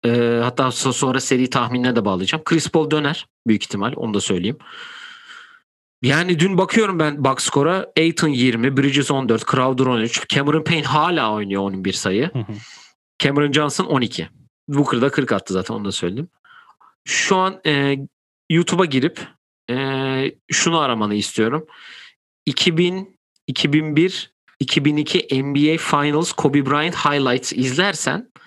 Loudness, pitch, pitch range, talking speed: -19 LUFS, 145 Hz, 125-165 Hz, 130 wpm